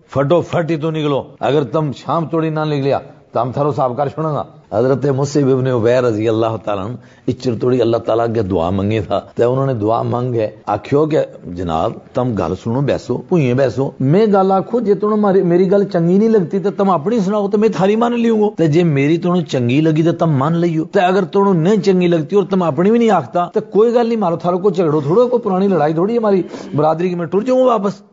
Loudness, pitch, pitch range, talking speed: -15 LUFS, 165 Hz, 130-195 Hz, 225 wpm